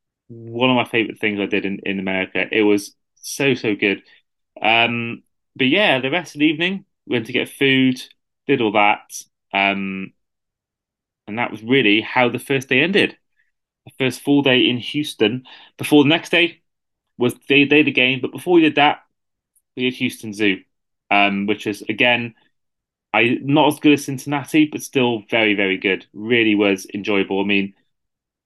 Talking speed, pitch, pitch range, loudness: 180 wpm, 120 Hz, 105-140 Hz, -18 LUFS